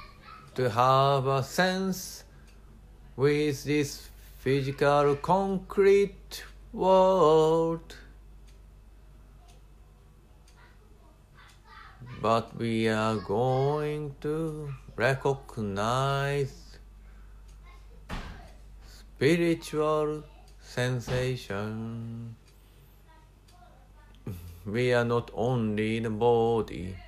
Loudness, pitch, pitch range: -27 LUFS, 130 Hz, 110-150 Hz